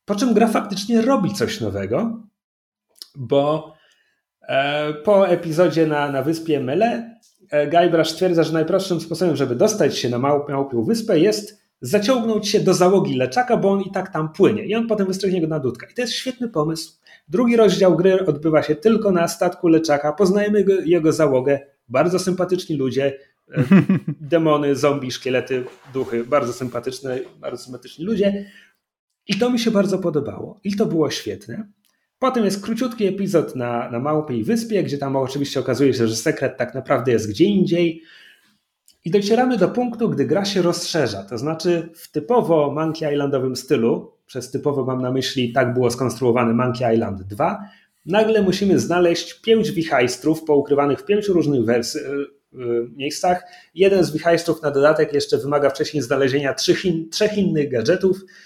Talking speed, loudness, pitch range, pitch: 160 wpm, -19 LUFS, 140-195 Hz, 160 Hz